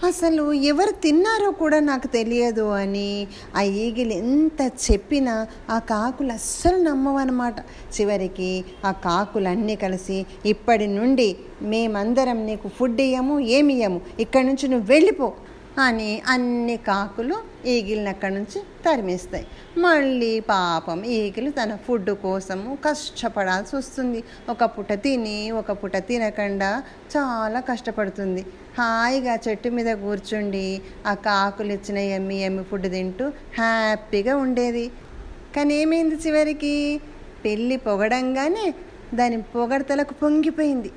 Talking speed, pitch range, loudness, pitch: 105 wpm, 205-275 Hz, -22 LUFS, 230 Hz